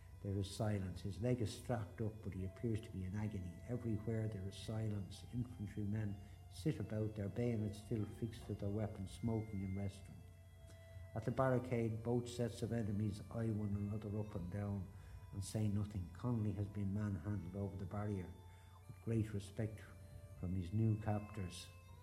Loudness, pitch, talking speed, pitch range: -43 LUFS, 105 Hz, 170 wpm, 95-110 Hz